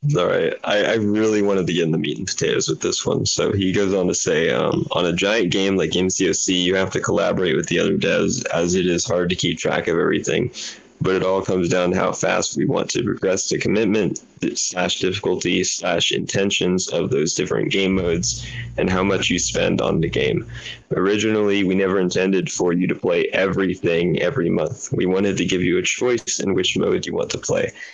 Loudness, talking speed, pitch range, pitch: -20 LUFS, 220 wpm, 90-100 Hz, 95 Hz